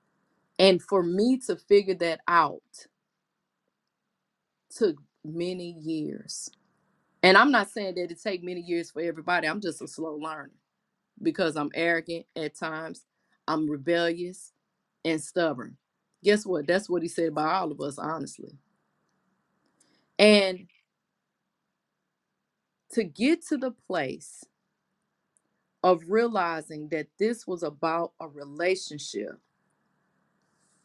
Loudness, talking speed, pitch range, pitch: -27 LUFS, 115 wpm, 165-200 Hz, 180 Hz